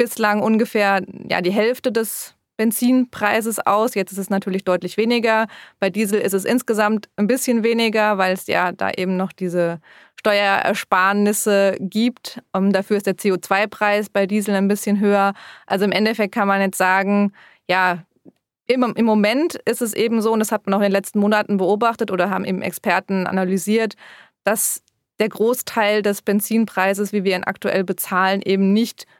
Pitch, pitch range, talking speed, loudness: 205 Hz, 195-220 Hz, 170 wpm, -19 LUFS